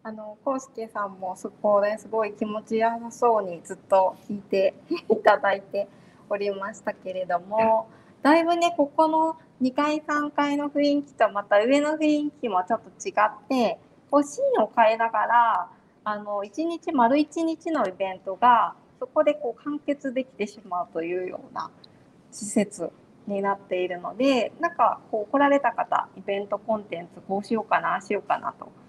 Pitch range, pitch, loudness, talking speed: 200-285 Hz, 220 Hz, -25 LUFS, 320 characters per minute